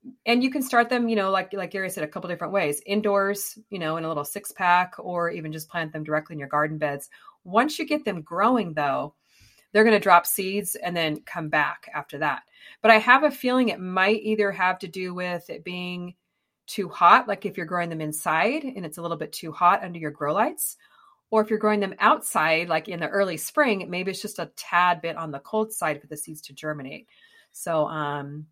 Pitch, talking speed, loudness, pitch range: 180 Hz, 235 wpm, -24 LUFS, 160-210 Hz